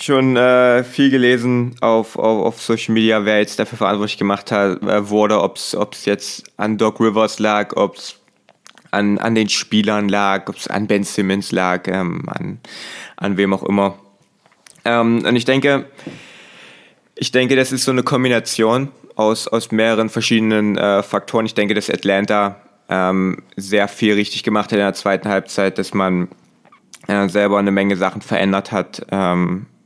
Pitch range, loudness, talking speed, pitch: 100-115 Hz, -17 LUFS, 170 wpm, 105 Hz